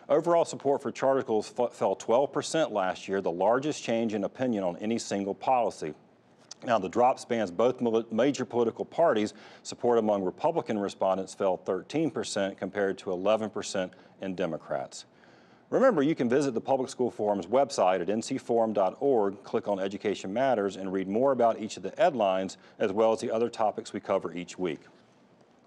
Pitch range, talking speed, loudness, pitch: 100-120 Hz, 170 wpm, -28 LUFS, 110 Hz